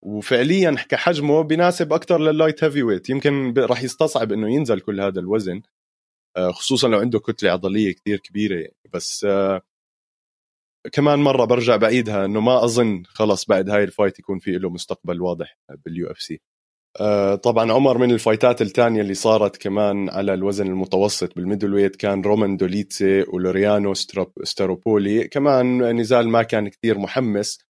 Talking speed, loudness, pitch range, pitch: 150 wpm, -19 LUFS, 100-125 Hz, 105 Hz